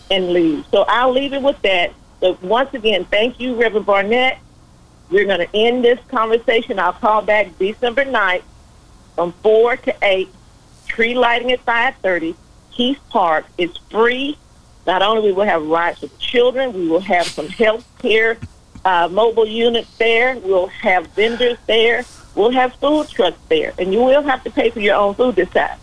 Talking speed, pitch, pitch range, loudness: 180 wpm, 225 Hz, 190-250 Hz, -16 LUFS